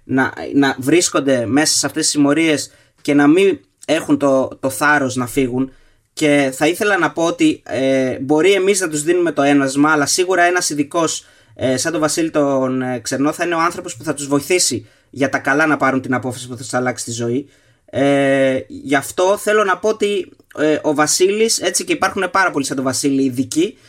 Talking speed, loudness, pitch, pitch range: 205 wpm, -16 LUFS, 145 Hz, 135-175 Hz